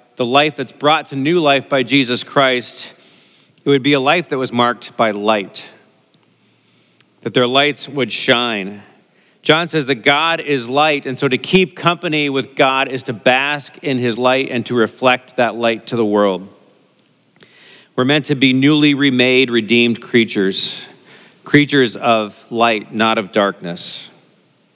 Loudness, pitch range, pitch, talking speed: -15 LUFS, 115-145 Hz, 130 Hz, 160 wpm